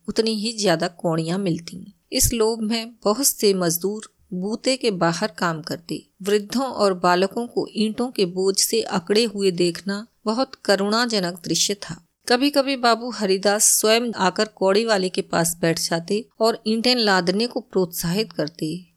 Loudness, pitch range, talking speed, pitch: -21 LUFS, 180-225 Hz, 155 wpm, 205 Hz